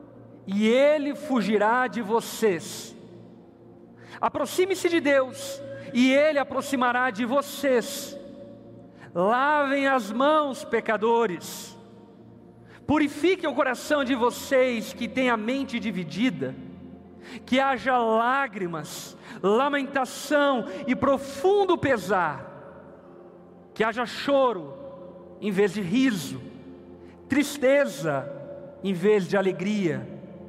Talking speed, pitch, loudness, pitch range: 90 wpm, 255 Hz, -24 LUFS, 210-275 Hz